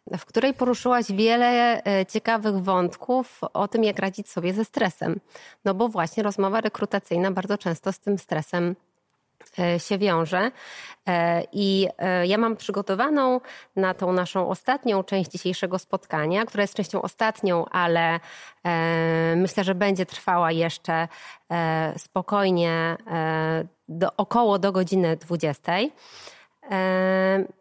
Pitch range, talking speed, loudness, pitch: 175-210 Hz, 115 wpm, -24 LUFS, 190 Hz